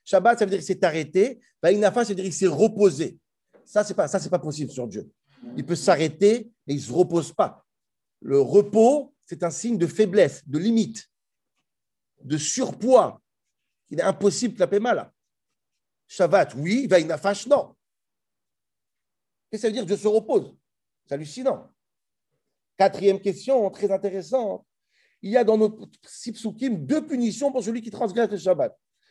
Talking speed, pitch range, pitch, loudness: 165 wpm, 180-230 Hz, 205 Hz, -23 LUFS